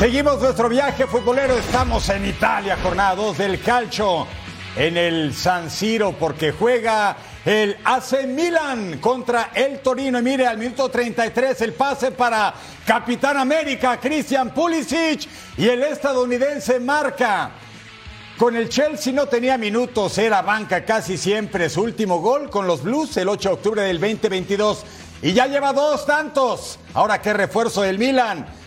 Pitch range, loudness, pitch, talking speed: 195-265 Hz, -20 LUFS, 230 Hz, 150 wpm